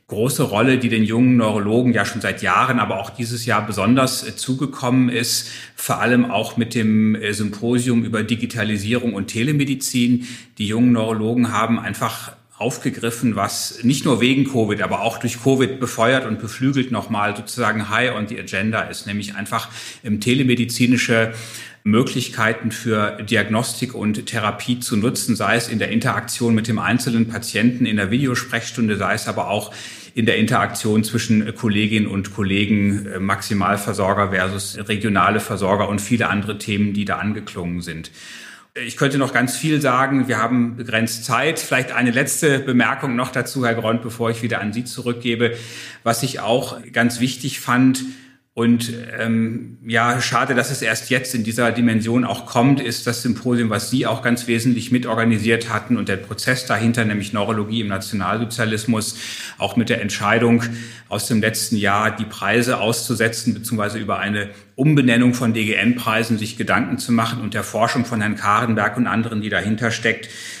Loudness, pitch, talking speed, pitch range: -19 LUFS, 115 Hz, 165 wpm, 110-120 Hz